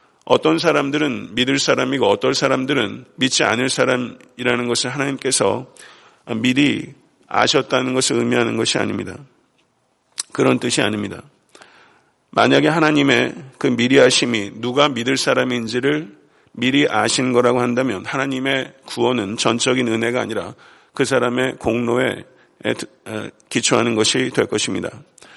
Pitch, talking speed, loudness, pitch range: 125 Hz, 300 characters per minute, -18 LUFS, 115-135 Hz